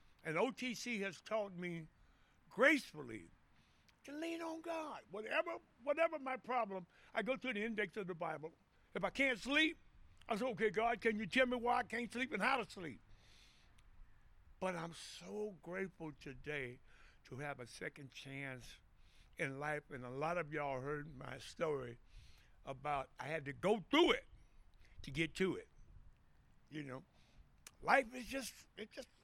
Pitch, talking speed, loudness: 195 Hz, 165 wpm, -40 LUFS